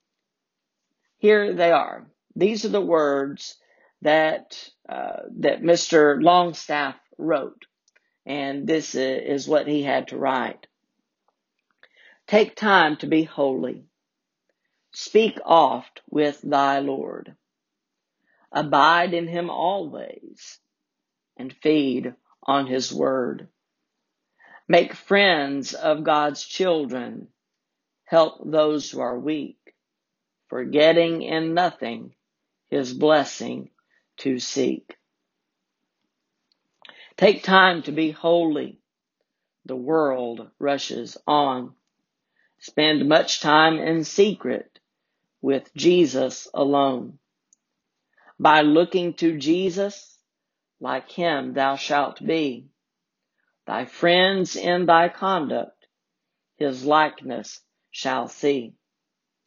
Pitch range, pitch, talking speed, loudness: 140-170 Hz, 155 Hz, 95 wpm, -21 LUFS